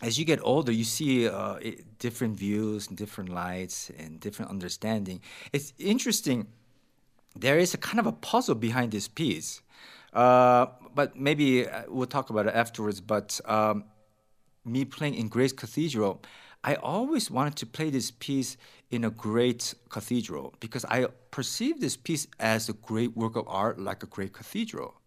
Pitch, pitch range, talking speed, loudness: 120 Hz, 110-135 Hz, 165 wpm, -29 LUFS